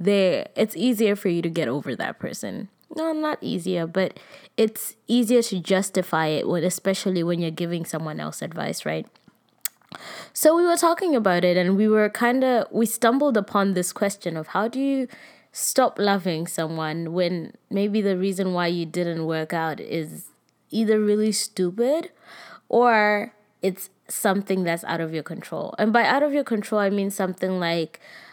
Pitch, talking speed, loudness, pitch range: 195 Hz, 170 wpm, -23 LUFS, 175-225 Hz